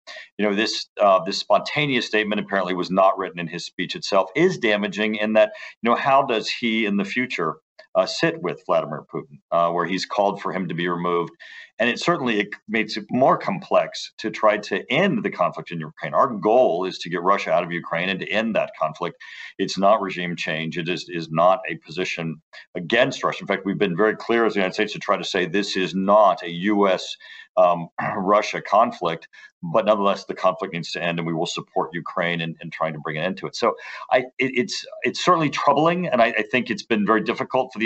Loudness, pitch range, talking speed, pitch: -22 LUFS, 85-115 Hz, 225 wpm, 100 Hz